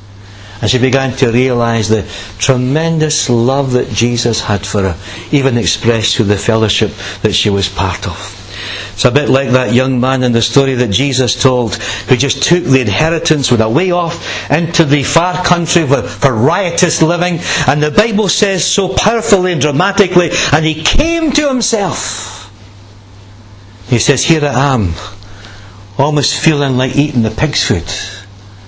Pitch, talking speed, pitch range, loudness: 130 Hz, 165 wpm, 105-155 Hz, -12 LUFS